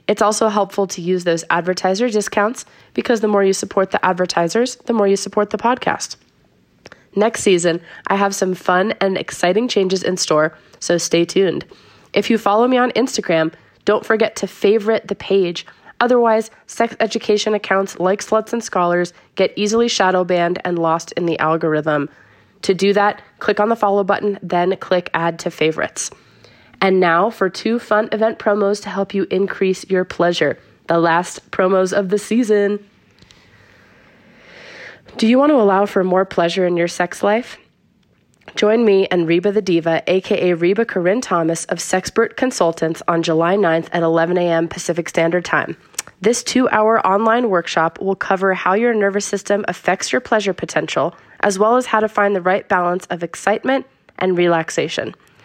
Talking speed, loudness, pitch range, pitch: 170 wpm, -17 LUFS, 175-210 Hz, 195 Hz